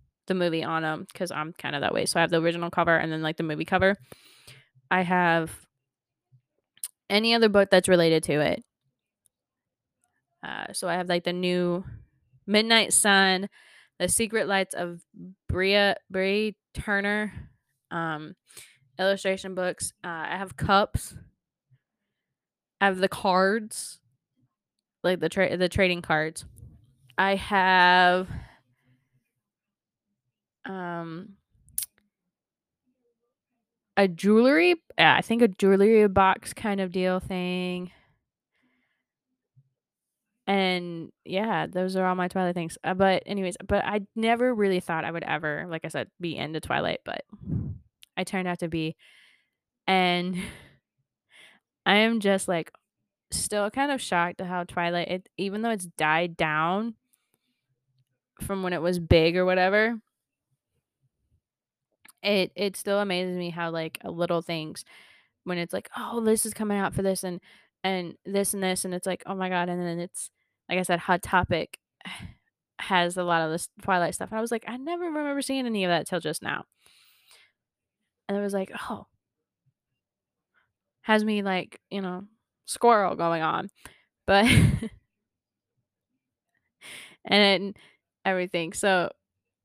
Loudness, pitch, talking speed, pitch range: -25 LUFS, 180 Hz, 140 wpm, 165-200 Hz